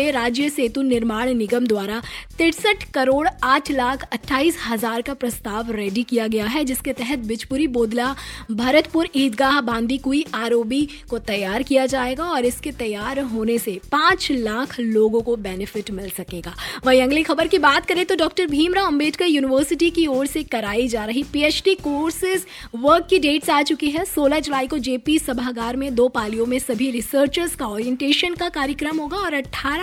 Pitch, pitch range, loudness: 270 Hz, 235-305 Hz, -20 LUFS